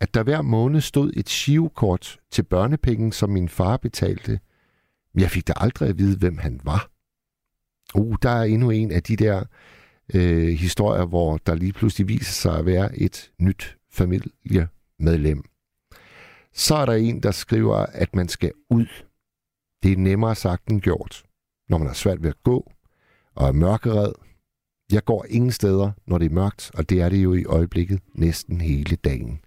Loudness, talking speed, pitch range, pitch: -22 LUFS, 180 wpm, 85-110 Hz, 95 Hz